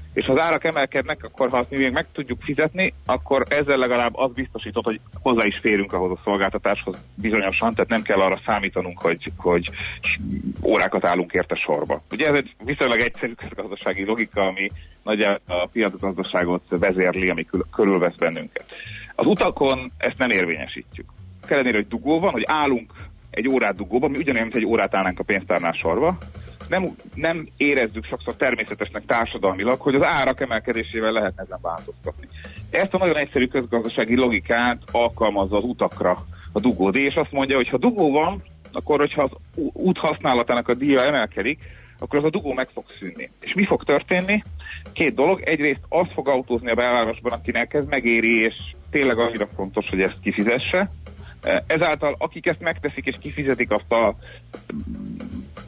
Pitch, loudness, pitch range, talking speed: 115 Hz, -22 LUFS, 100-135 Hz, 165 wpm